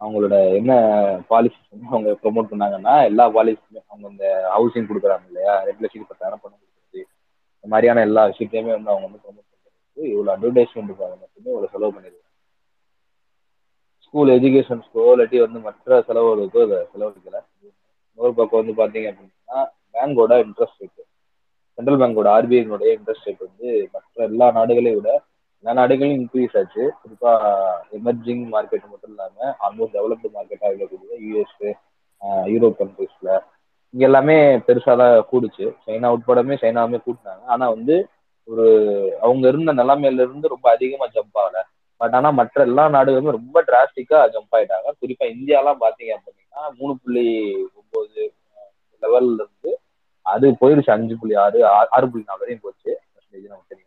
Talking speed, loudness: 135 wpm, -17 LUFS